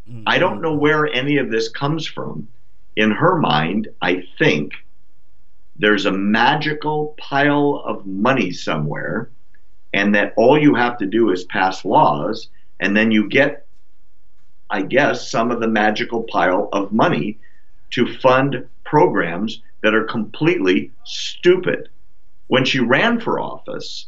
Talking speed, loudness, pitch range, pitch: 140 wpm, -18 LUFS, 105-145 Hz, 115 Hz